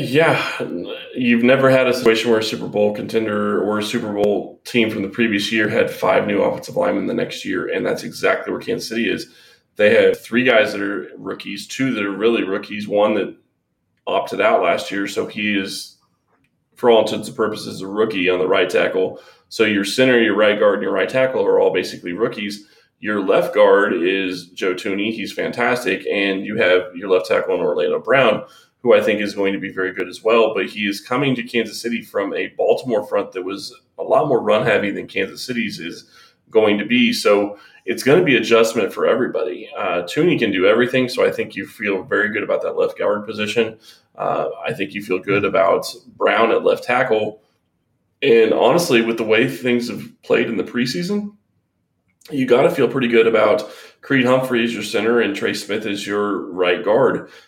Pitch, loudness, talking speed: 115 Hz, -18 LUFS, 210 wpm